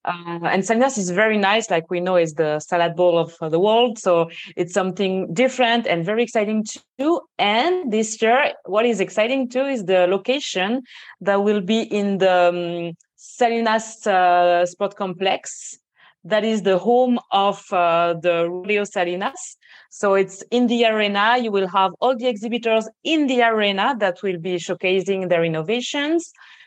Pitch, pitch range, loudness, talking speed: 205 Hz, 180-235 Hz, -20 LUFS, 165 wpm